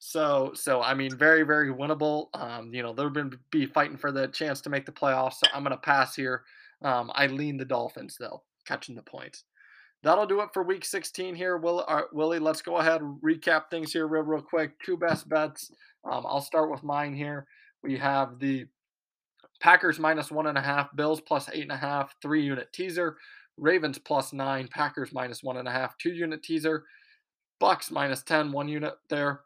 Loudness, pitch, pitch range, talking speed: -28 LUFS, 150 Hz, 135-160 Hz, 205 wpm